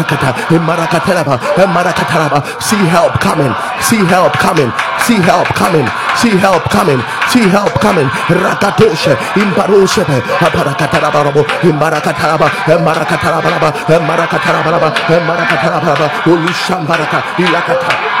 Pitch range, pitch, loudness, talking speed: 155-175 Hz, 165 Hz, -10 LUFS, 115 wpm